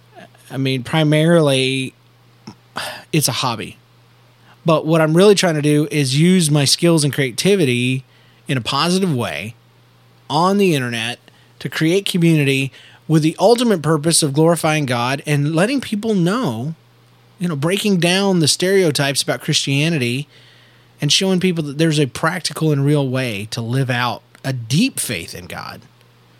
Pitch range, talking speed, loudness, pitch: 125-170 Hz, 150 wpm, -17 LUFS, 150 Hz